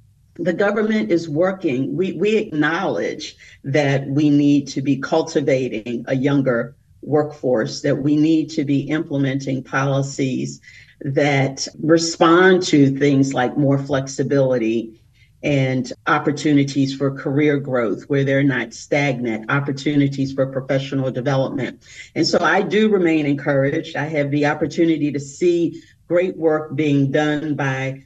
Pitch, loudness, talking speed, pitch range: 145 Hz, -19 LUFS, 130 wpm, 135-155 Hz